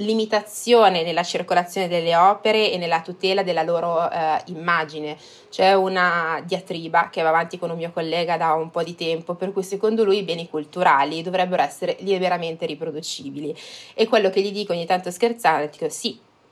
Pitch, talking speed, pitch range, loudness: 175 Hz, 175 wpm, 165-190 Hz, -21 LUFS